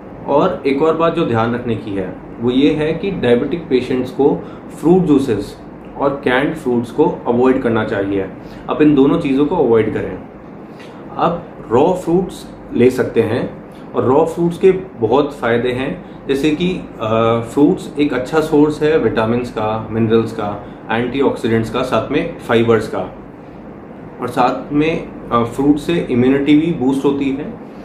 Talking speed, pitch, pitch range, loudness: 155 wpm, 135 Hz, 115-155 Hz, -16 LUFS